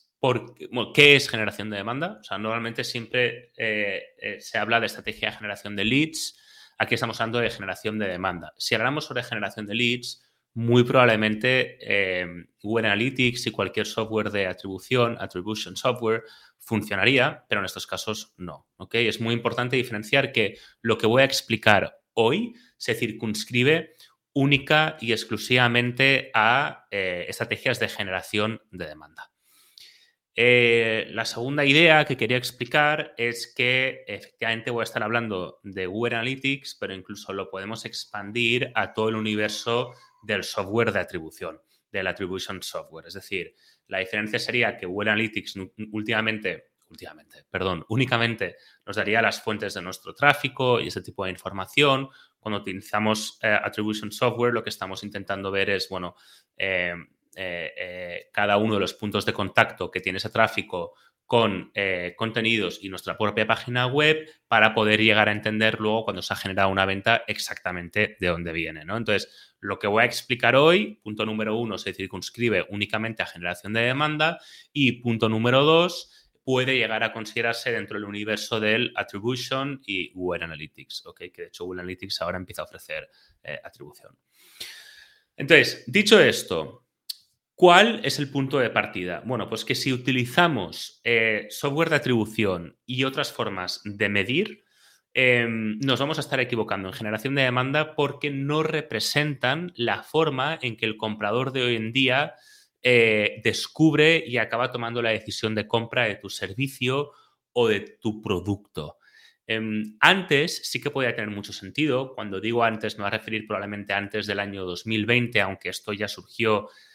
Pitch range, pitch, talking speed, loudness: 105-130 Hz, 115 Hz, 160 wpm, -24 LUFS